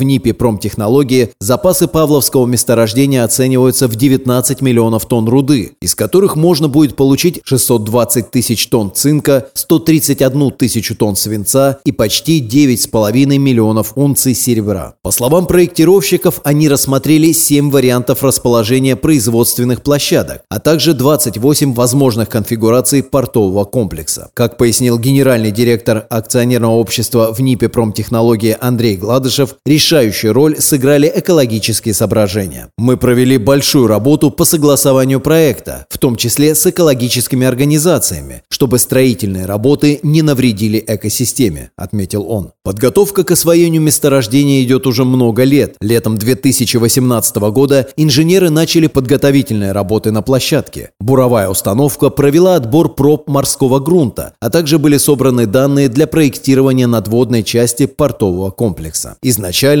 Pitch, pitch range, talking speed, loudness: 130 Hz, 115-145 Hz, 120 wpm, -11 LUFS